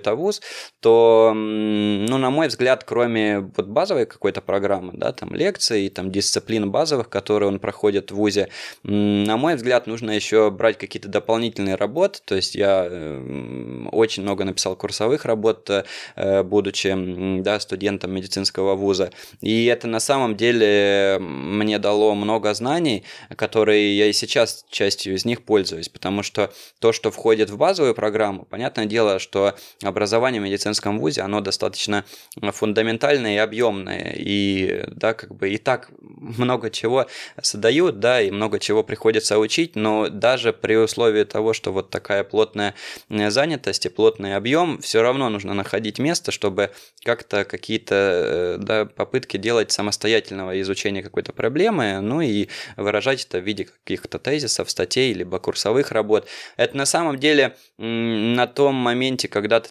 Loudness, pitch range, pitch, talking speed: -21 LUFS, 100-115 Hz, 105 Hz, 145 wpm